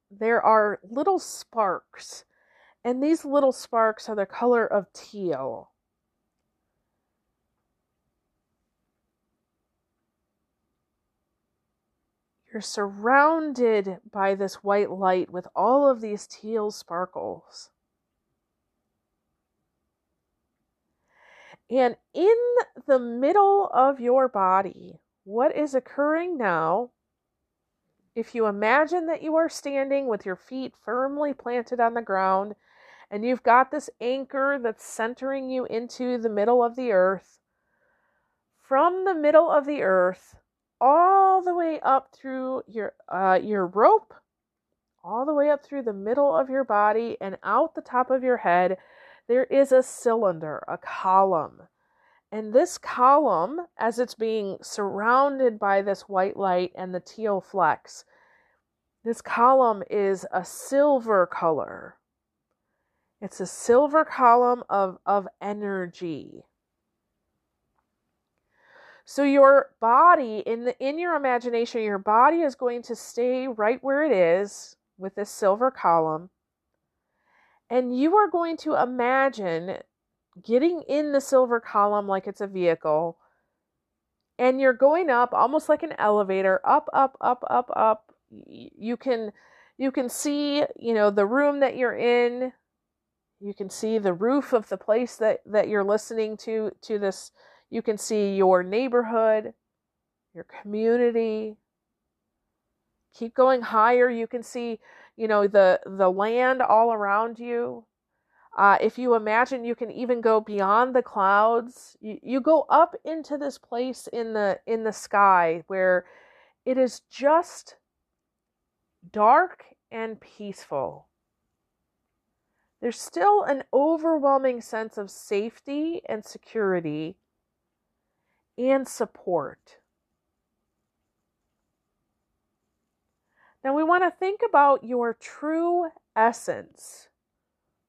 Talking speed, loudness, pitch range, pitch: 120 wpm, -23 LUFS, 205-275 Hz, 235 Hz